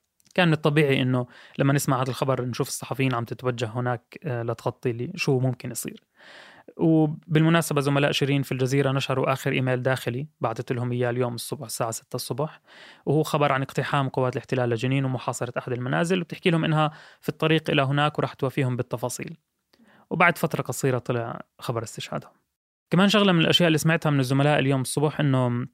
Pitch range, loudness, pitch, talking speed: 125-155 Hz, -24 LUFS, 135 Hz, 170 wpm